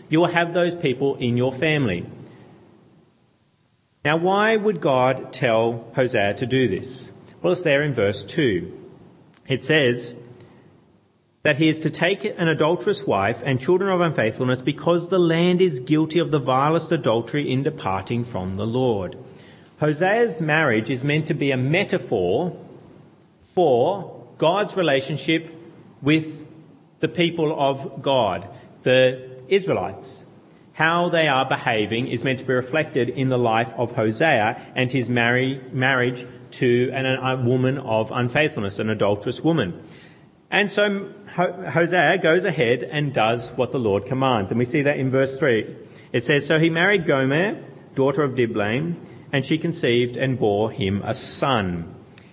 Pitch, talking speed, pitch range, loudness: 140 Hz, 150 wpm, 125-165 Hz, -21 LUFS